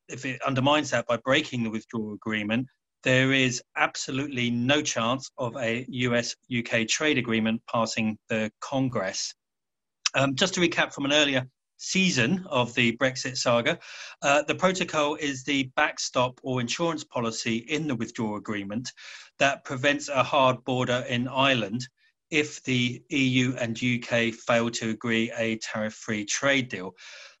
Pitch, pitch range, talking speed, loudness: 125 Hz, 115-145 Hz, 150 wpm, -26 LUFS